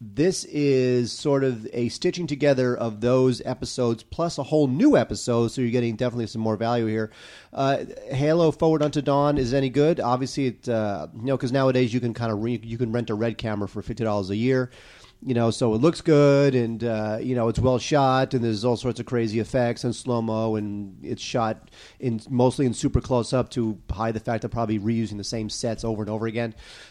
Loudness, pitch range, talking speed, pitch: -24 LUFS, 115-130 Hz, 225 wpm, 120 Hz